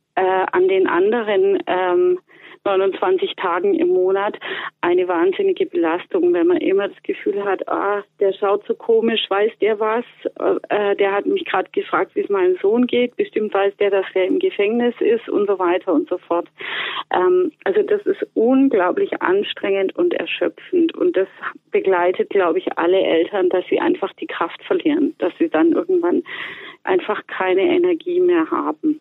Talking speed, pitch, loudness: 165 wpm, 345 Hz, -19 LUFS